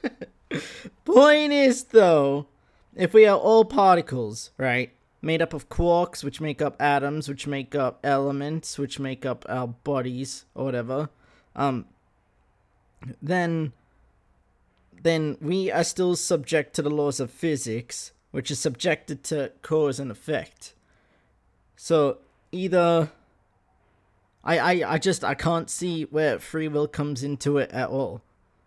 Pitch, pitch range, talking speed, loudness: 145 Hz, 130-165 Hz, 135 wpm, -24 LUFS